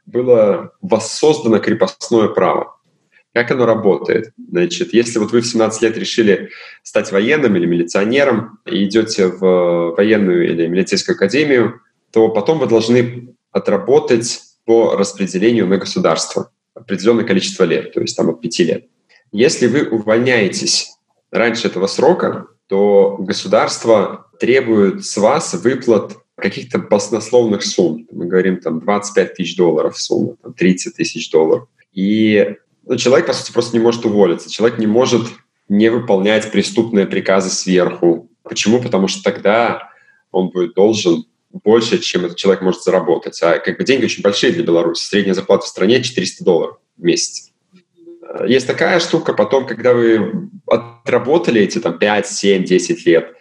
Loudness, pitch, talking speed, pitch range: -15 LUFS, 115 Hz, 145 wpm, 95-125 Hz